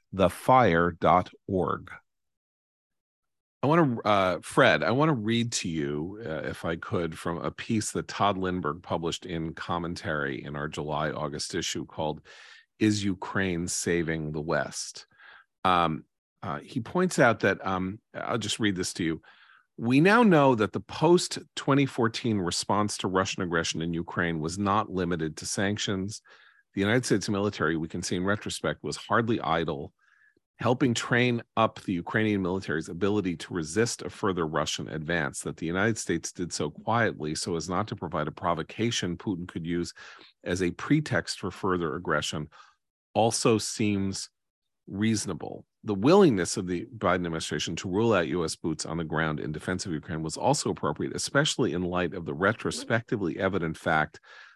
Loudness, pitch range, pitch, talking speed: -28 LUFS, 80-110 Hz, 95 Hz, 160 wpm